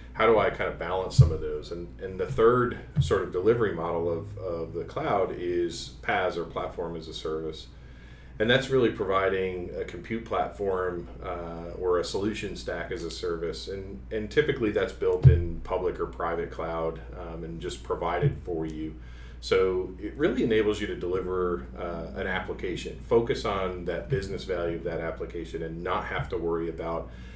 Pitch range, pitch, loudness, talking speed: 80-100 Hz, 90 Hz, -28 LUFS, 180 wpm